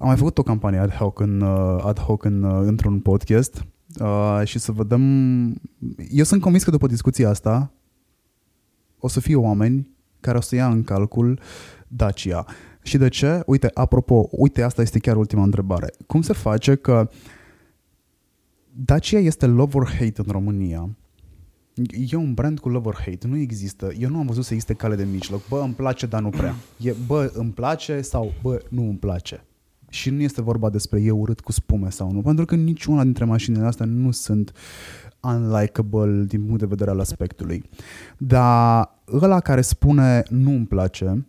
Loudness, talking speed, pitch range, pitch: -20 LUFS, 175 wpm, 100-130 Hz, 115 Hz